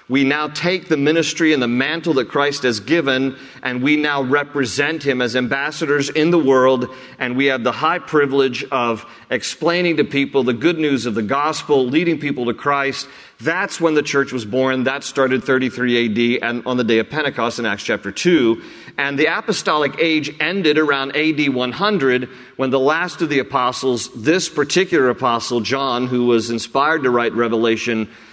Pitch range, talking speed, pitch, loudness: 125-150 Hz, 180 wpm, 135 Hz, -18 LUFS